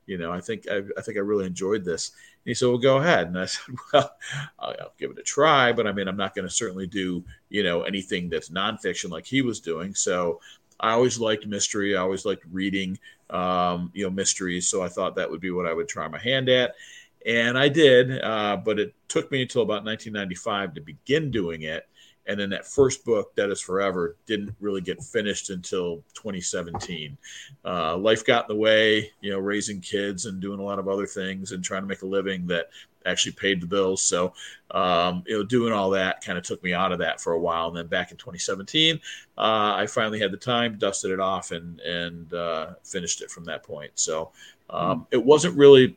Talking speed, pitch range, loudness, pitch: 225 wpm, 95-115 Hz, -25 LUFS, 100 Hz